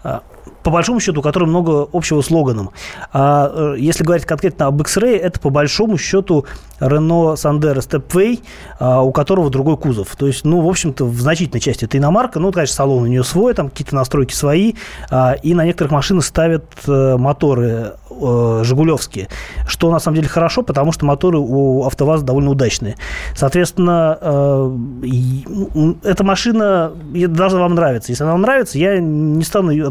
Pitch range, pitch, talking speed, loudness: 135-175 Hz, 155 Hz, 155 wpm, -15 LUFS